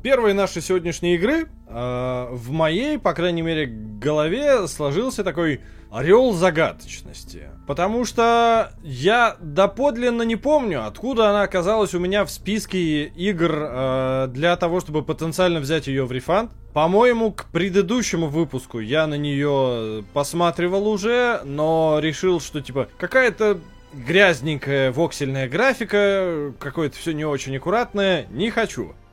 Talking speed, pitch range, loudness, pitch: 130 wpm, 145-205 Hz, -21 LUFS, 170 Hz